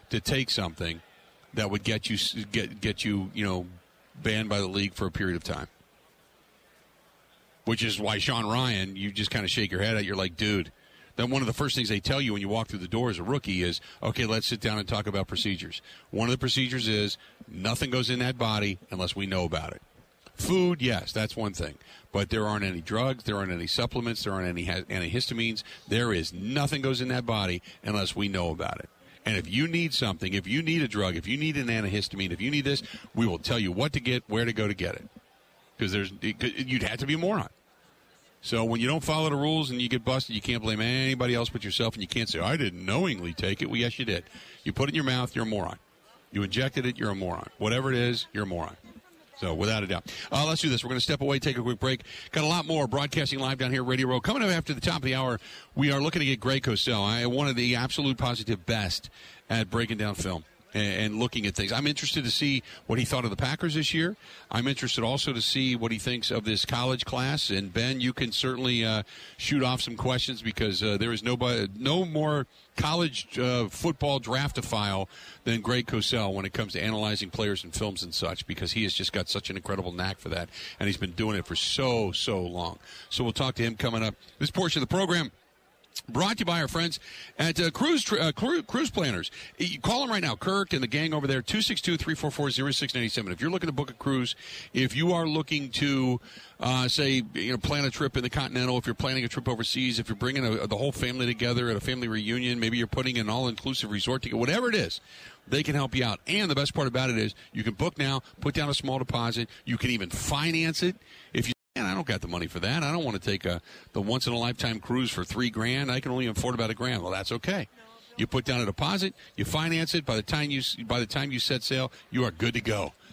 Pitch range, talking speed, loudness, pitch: 105-135 Hz, 250 wpm, -28 LUFS, 120 Hz